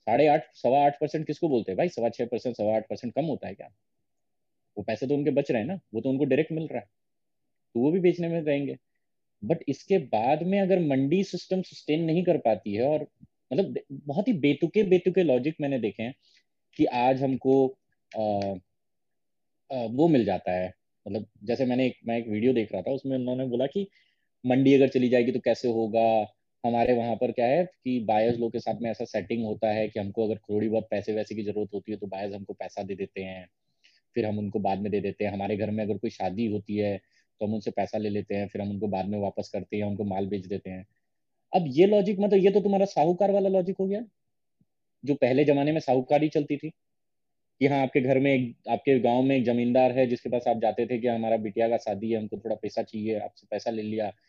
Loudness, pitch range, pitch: -27 LUFS, 105-145 Hz, 120 Hz